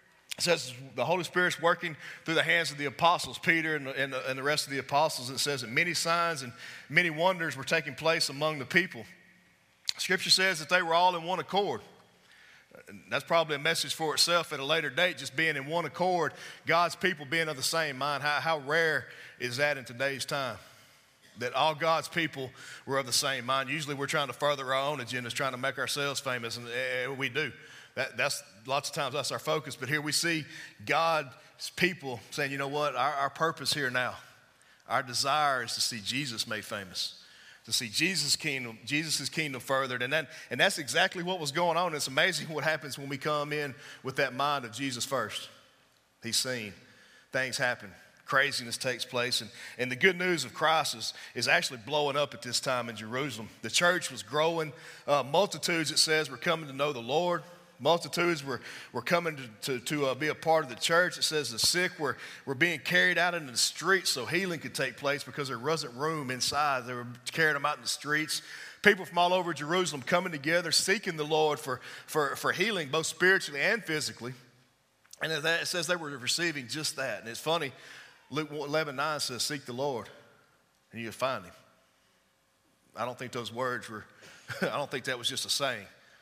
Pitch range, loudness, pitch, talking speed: 130-165 Hz, -29 LUFS, 150 Hz, 210 wpm